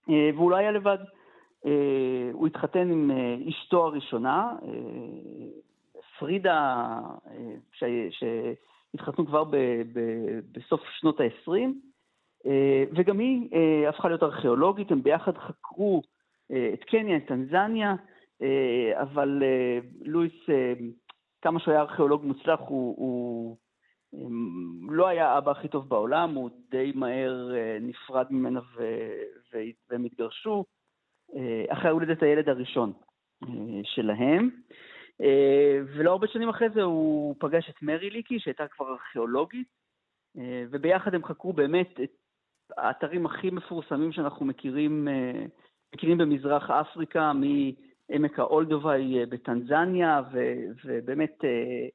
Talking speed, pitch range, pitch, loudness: 100 wpm, 130-175 Hz, 150 Hz, -27 LUFS